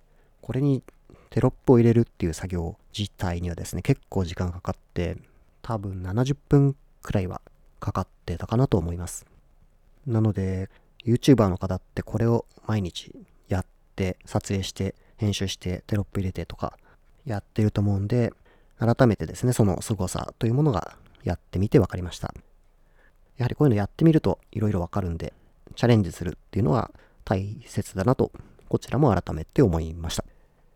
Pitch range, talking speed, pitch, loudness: 90-115 Hz, 355 characters per minute, 100 Hz, -26 LUFS